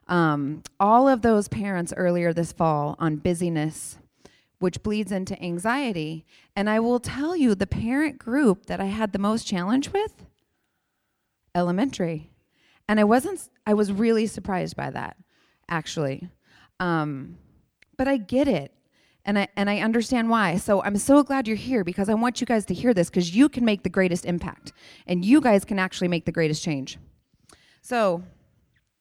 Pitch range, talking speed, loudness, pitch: 175-235 Hz, 170 wpm, -24 LUFS, 200 Hz